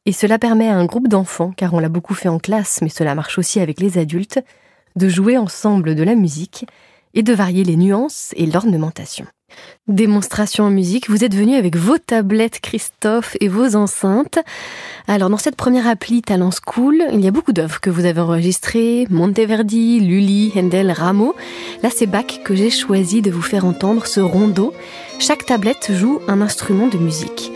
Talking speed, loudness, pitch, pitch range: 185 wpm, -16 LUFS, 205 Hz, 180-230 Hz